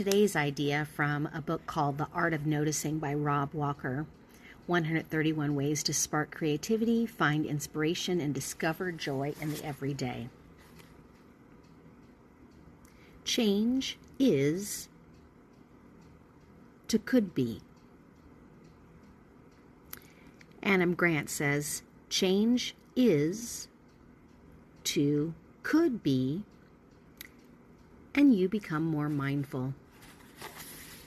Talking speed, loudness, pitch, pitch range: 85 wpm, -31 LUFS, 155 Hz, 145-195 Hz